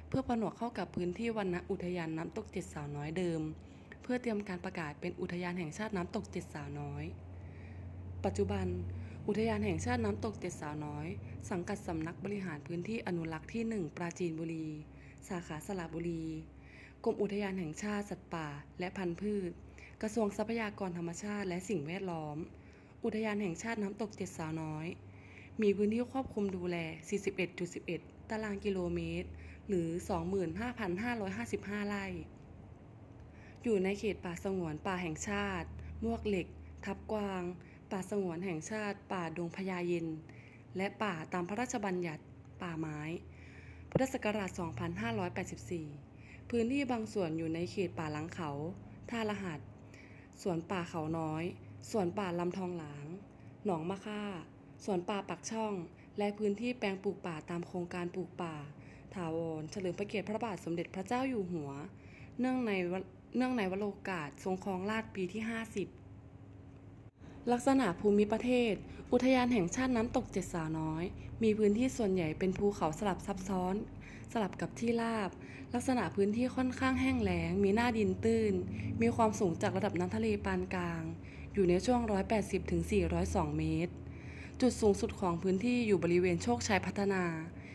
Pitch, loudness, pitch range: 185 Hz, -37 LUFS, 165-210 Hz